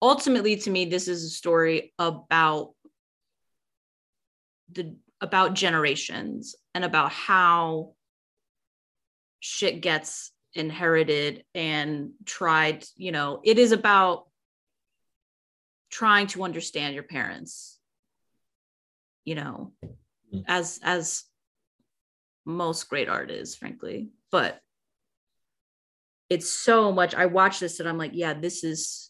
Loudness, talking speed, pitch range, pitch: -24 LUFS, 105 wpm, 150-185 Hz, 165 Hz